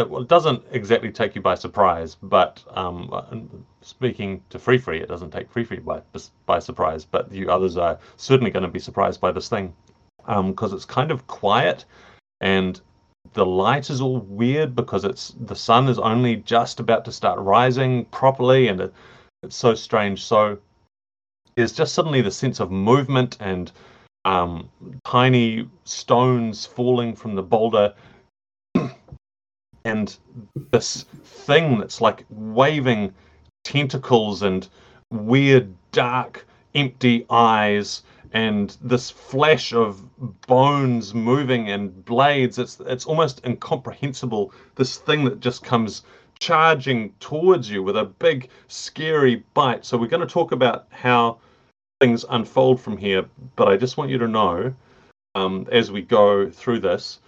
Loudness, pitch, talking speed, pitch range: -21 LUFS, 115 Hz, 145 wpm, 100-130 Hz